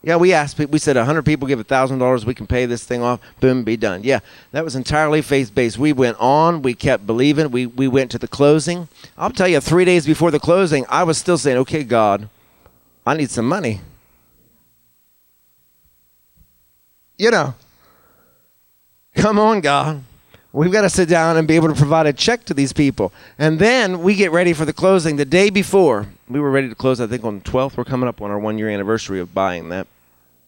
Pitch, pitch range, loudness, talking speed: 130 Hz, 110-160 Hz, -17 LUFS, 205 wpm